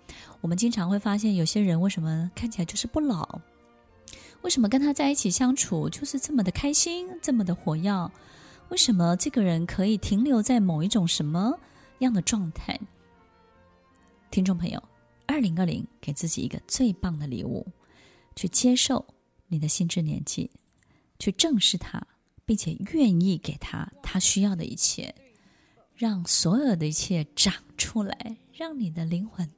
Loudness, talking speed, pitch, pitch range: -25 LUFS, 240 characters per minute, 195 Hz, 170-240 Hz